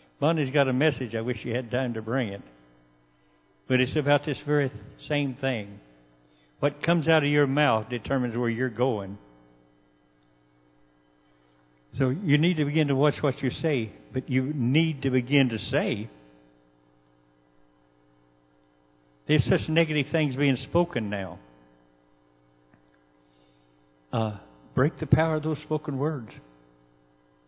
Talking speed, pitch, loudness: 140 wpm, 110 Hz, -26 LUFS